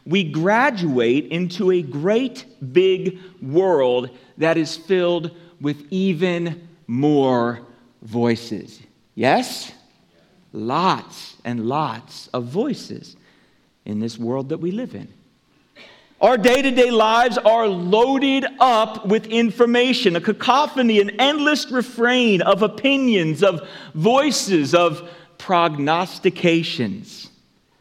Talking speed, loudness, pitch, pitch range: 105 wpm, -19 LUFS, 185 Hz, 155-230 Hz